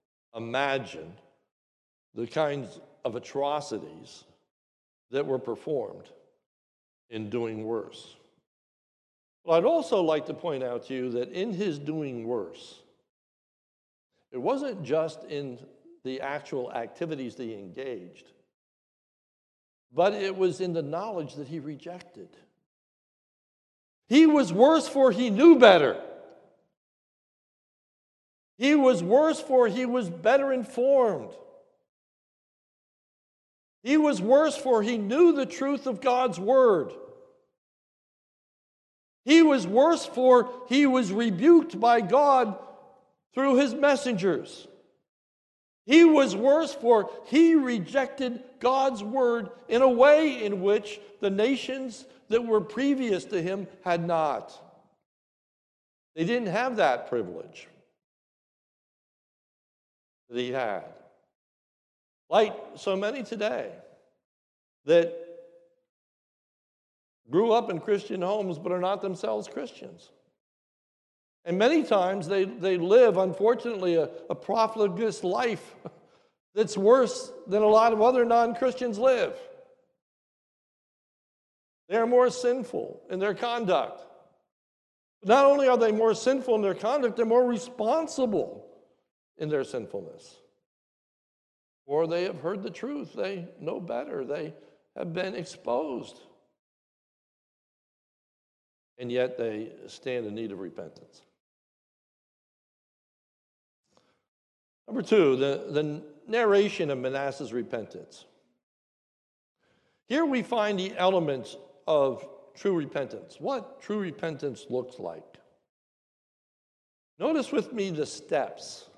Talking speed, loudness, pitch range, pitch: 110 wpm, -25 LUFS, 165-265 Hz, 215 Hz